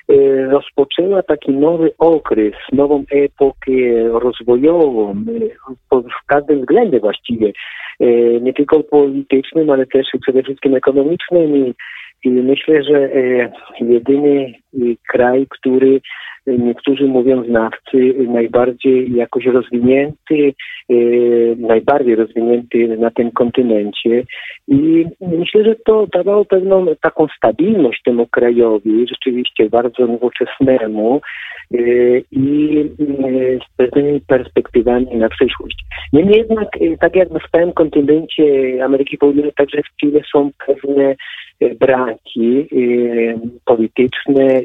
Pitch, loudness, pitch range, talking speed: 135 Hz, -14 LUFS, 120-150 Hz, 100 wpm